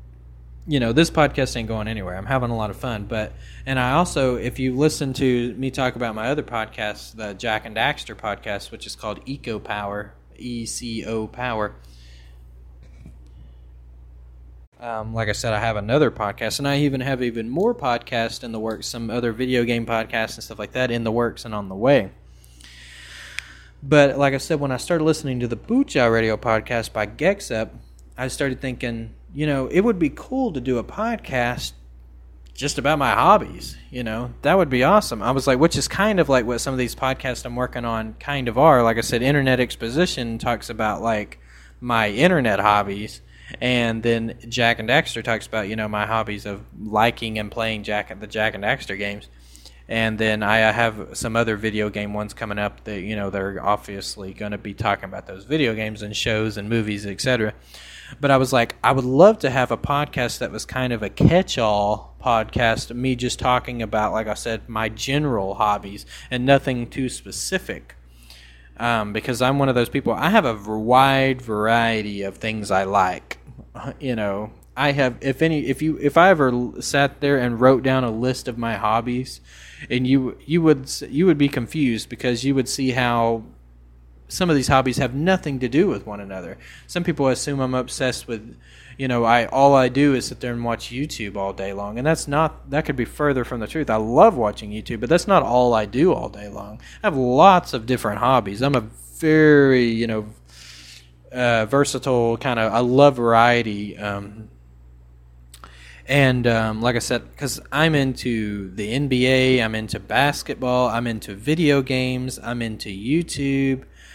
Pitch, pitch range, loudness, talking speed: 115 Hz, 105-130 Hz, -21 LUFS, 195 wpm